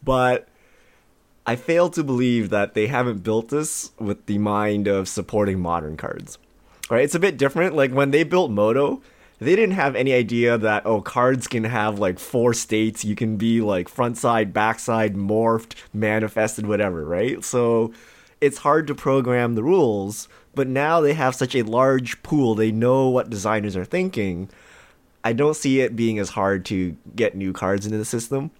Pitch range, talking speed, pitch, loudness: 105-130 Hz, 185 wpm, 115 Hz, -21 LUFS